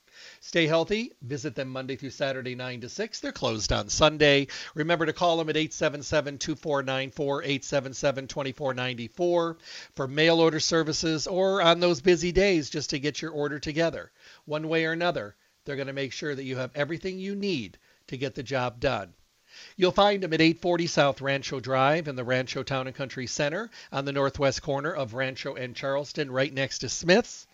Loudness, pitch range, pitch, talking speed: -27 LUFS, 135-165 Hz, 145 Hz, 185 wpm